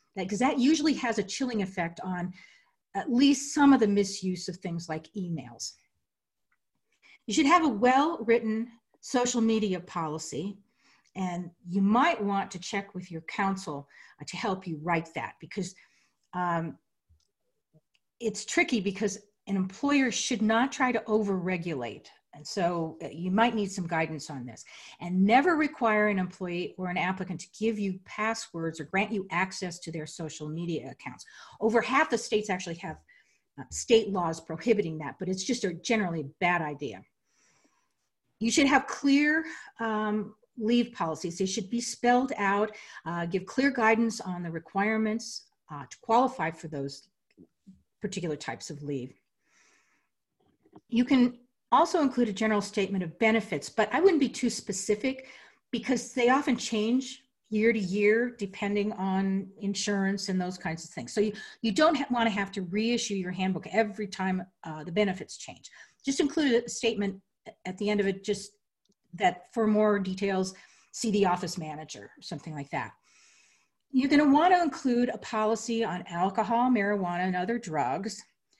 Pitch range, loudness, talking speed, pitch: 180-235 Hz, -28 LUFS, 160 wpm, 205 Hz